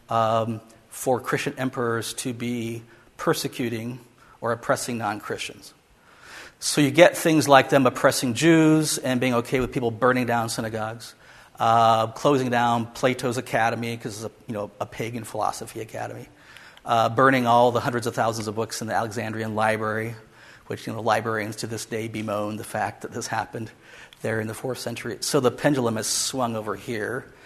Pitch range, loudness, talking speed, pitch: 110-130 Hz, -24 LUFS, 175 wpm, 115 Hz